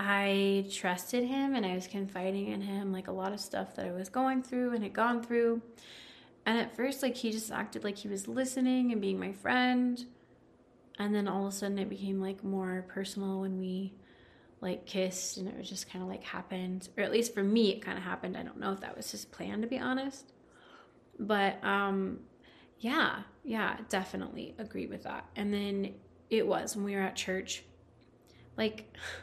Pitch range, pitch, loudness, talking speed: 190-230 Hz, 200 Hz, -34 LUFS, 205 wpm